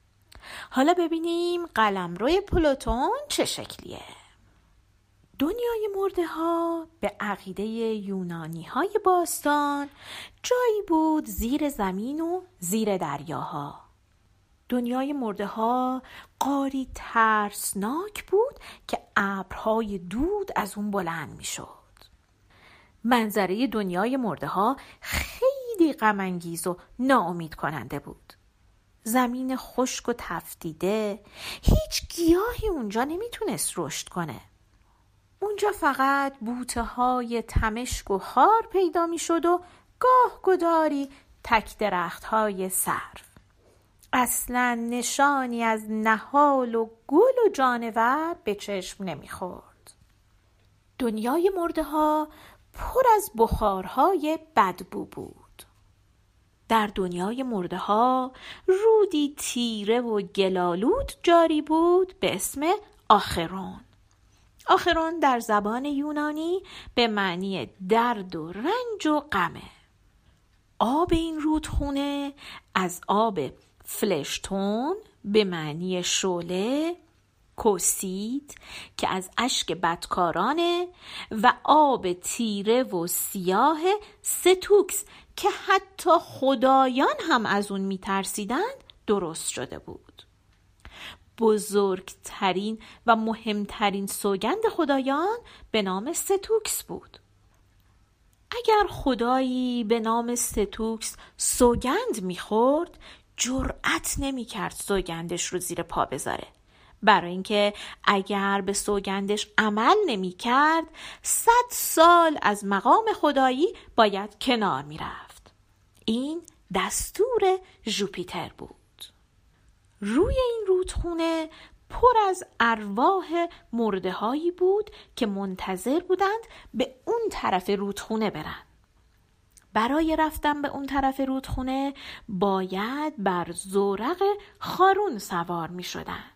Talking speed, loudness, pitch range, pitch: 95 wpm, -25 LUFS, 195-330 Hz, 240 Hz